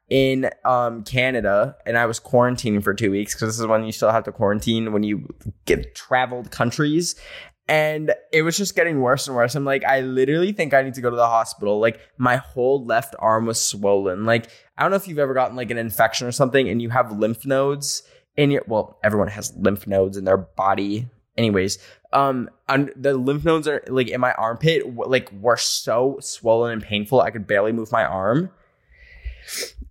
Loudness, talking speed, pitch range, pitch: -21 LUFS, 205 wpm, 110-135 Hz, 120 Hz